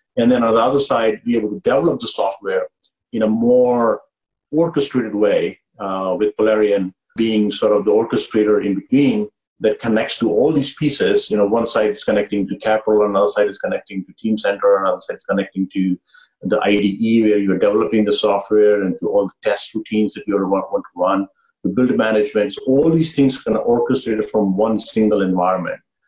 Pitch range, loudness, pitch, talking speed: 100-125 Hz, -17 LUFS, 110 Hz, 205 wpm